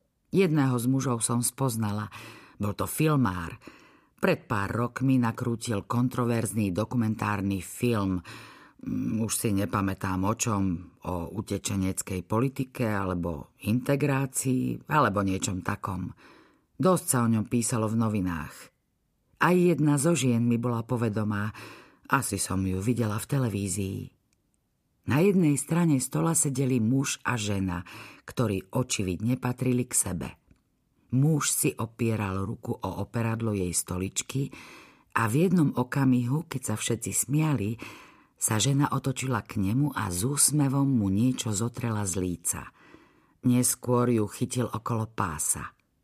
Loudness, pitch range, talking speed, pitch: -27 LUFS, 100-130 Hz, 125 wpm, 115 Hz